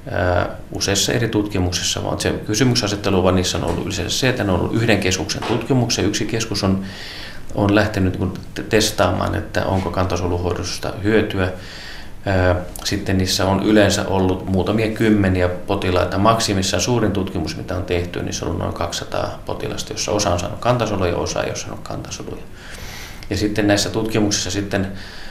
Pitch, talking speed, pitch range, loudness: 95 Hz, 155 wpm, 90-105 Hz, -19 LUFS